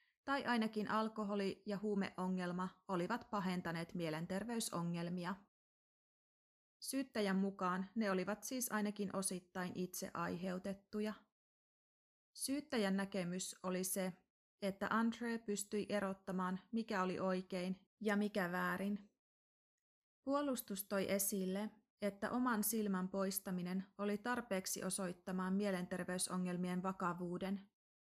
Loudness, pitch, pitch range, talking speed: -42 LUFS, 195 Hz, 185-215 Hz, 90 wpm